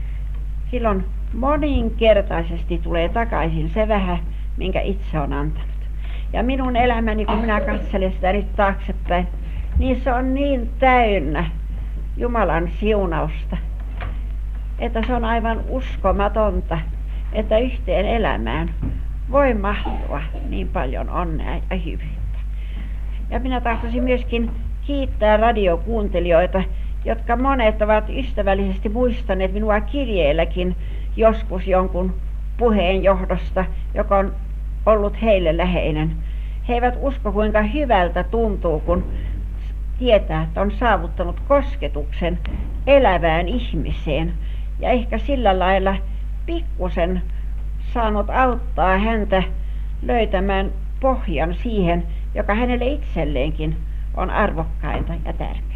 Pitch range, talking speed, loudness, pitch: 165-230 Hz, 100 wpm, -21 LUFS, 195 Hz